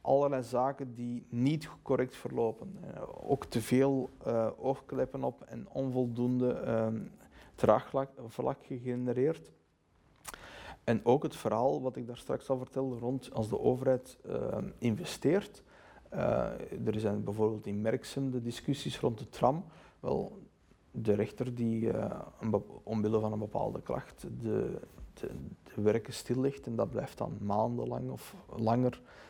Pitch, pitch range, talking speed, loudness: 120 Hz, 110-130 Hz, 135 wpm, -34 LUFS